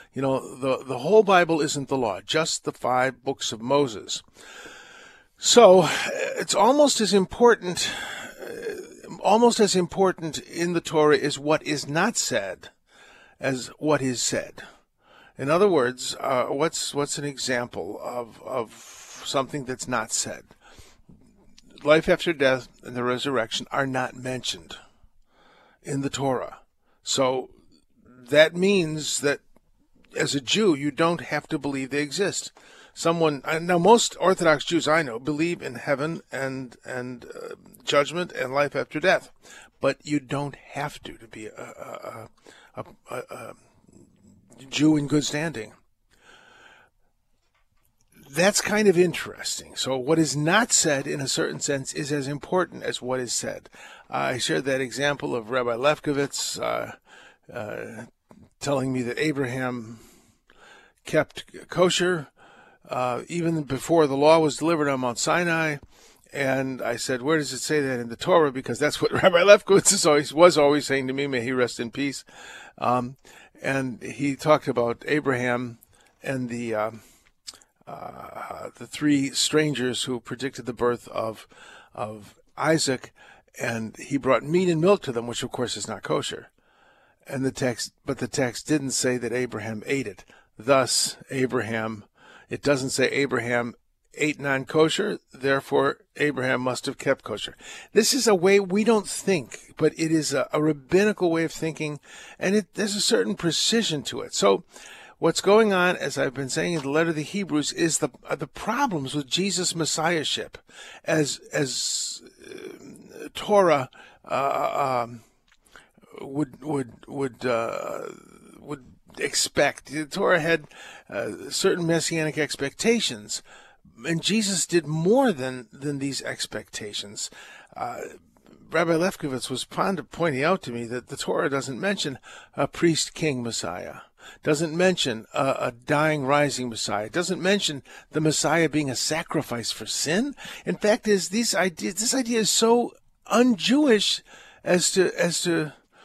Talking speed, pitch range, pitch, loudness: 150 wpm, 130-175 Hz, 150 Hz, -24 LUFS